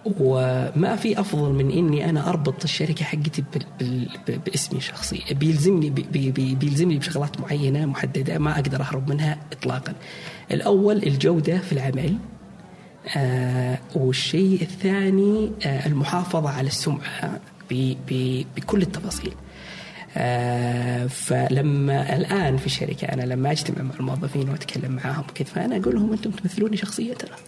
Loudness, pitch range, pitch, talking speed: -23 LUFS, 135-180 Hz, 150 Hz, 135 wpm